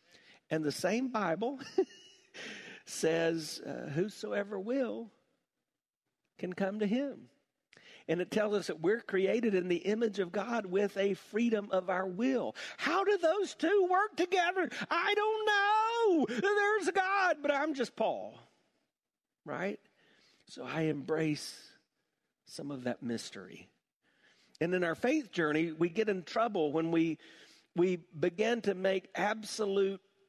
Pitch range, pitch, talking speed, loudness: 180-290 Hz, 210 Hz, 135 wpm, -33 LUFS